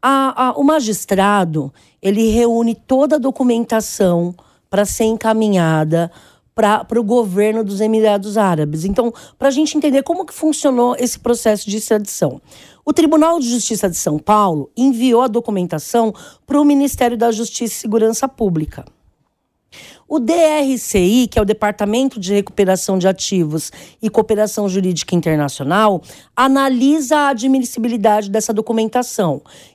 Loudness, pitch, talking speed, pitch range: -16 LUFS, 225 Hz, 135 wpm, 200-255 Hz